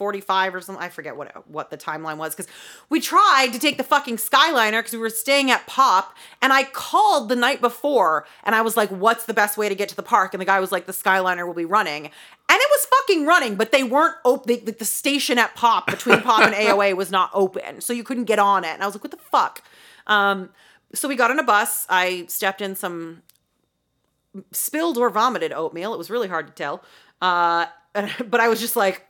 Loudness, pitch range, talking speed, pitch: -20 LUFS, 190-255 Hz, 235 wpm, 220 Hz